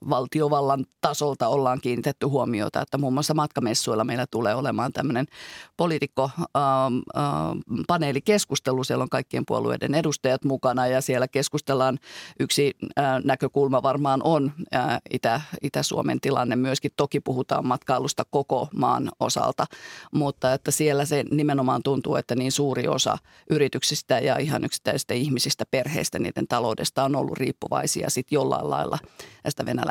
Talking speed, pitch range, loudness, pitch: 130 wpm, 130-145 Hz, -25 LUFS, 135 Hz